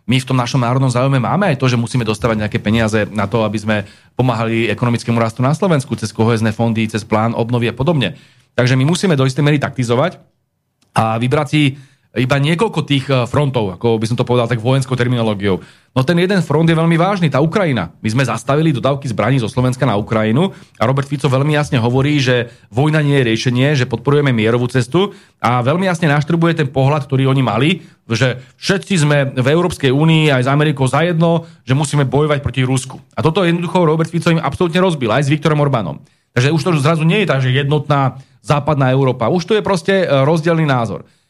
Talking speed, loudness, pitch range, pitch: 200 wpm, -15 LUFS, 120-155 Hz, 135 Hz